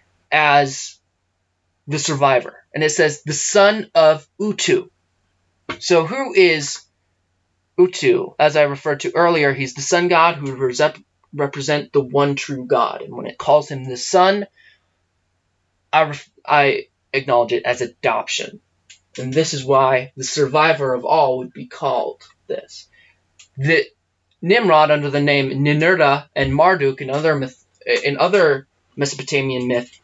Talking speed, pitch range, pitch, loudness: 140 wpm, 130-165 Hz, 145 Hz, -17 LUFS